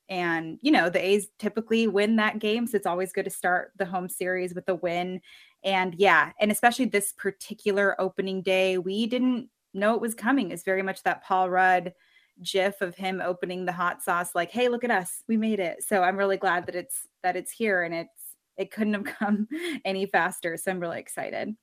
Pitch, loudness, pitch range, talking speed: 195 Hz, -26 LUFS, 185-215 Hz, 215 wpm